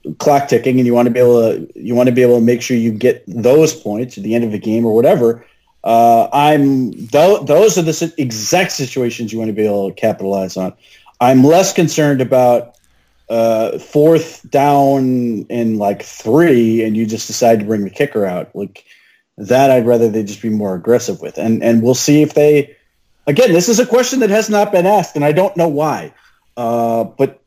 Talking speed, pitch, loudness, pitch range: 210 wpm, 120 Hz, -13 LUFS, 115-150 Hz